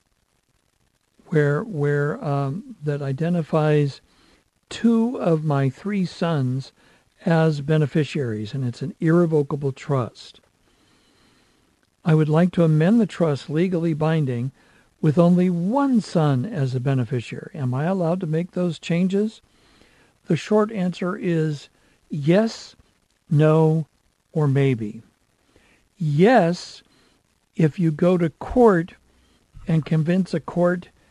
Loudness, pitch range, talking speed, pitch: -21 LUFS, 145-180 Hz, 110 wpm, 160 Hz